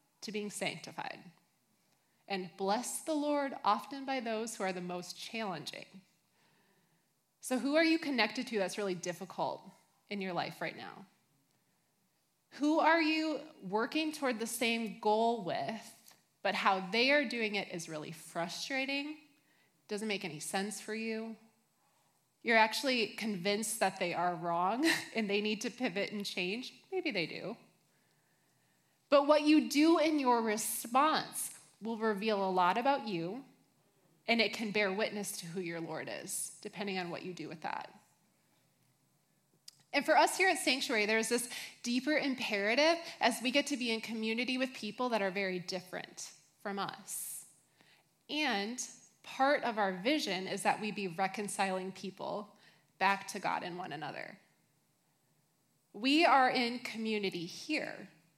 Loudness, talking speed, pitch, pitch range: -34 LUFS, 150 wpm, 215 Hz, 190-260 Hz